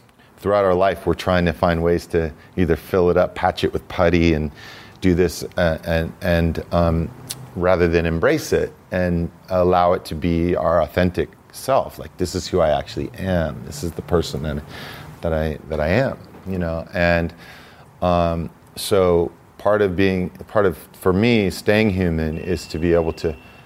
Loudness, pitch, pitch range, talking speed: -20 LUFS, 85 Hz, 85-95 Hz, 185 wpm